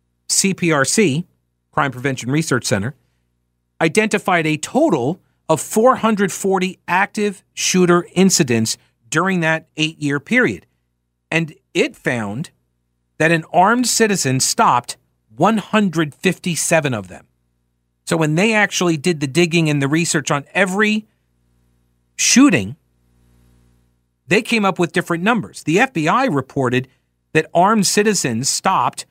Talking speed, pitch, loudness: 115 wpm, 155 Hz, -17 LUFS